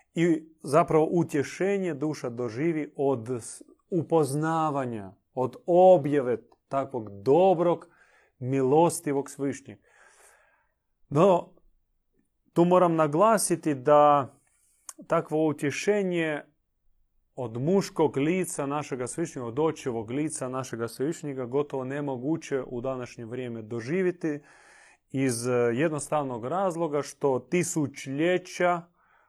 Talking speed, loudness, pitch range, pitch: 85 wpm, -27 LUFS, 130-165 Hz, 145 Hz